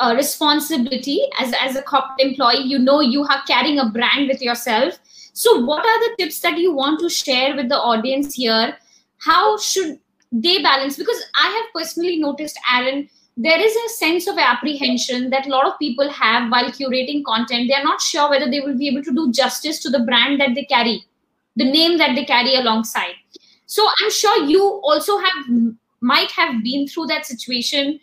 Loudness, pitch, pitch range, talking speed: -17 LUFS, 280 Hz, 250-320 Hz, 195 wpm